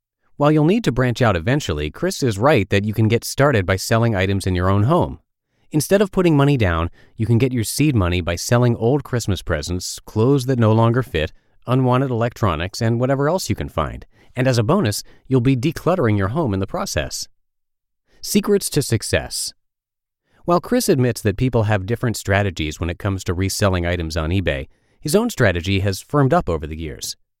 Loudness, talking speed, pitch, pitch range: -19 LUFS, 200 wpm, 115 Hz, 95-135 Hz